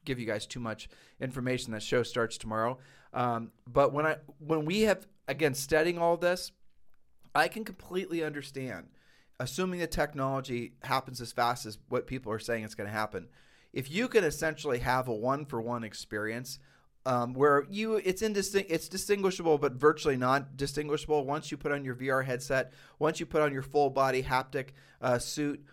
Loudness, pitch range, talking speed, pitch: -31 LUFS, 125-155 Hz, 185 wpm, 135 Hz